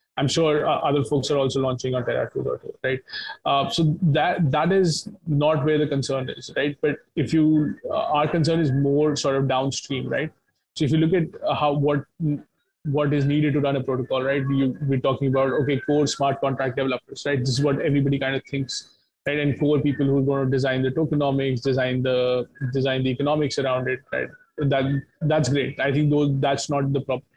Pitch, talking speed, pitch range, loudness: 140 Hz, 210 wpm, 135-150 Hz, -23 LUFS